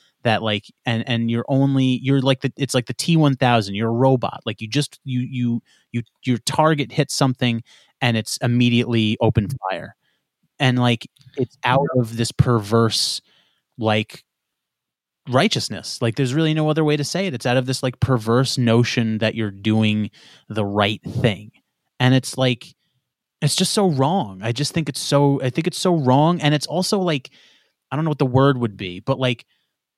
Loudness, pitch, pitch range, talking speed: -20 LUFS, 125 Hz, 115-140 Hz, 185 wpm